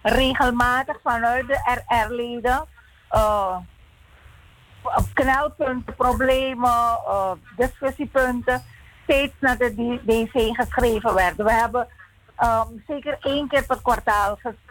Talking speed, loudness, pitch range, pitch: 100 wpm, -22 LUFS, 230-265 Hz, 245 Hz